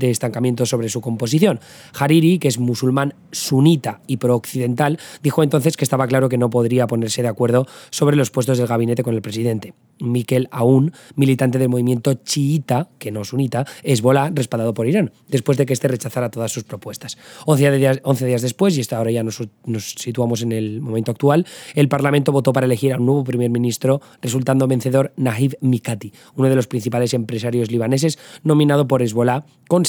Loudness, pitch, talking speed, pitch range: -18 LUFS, 130 Hz, 185 wpm, 120-140 Hz